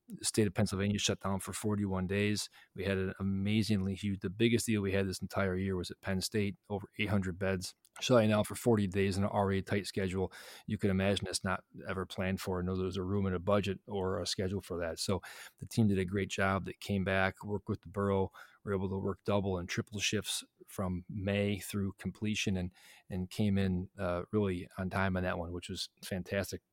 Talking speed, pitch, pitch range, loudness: 225 wpm, 95 Hz, 95-105 Hz, -34 LUFS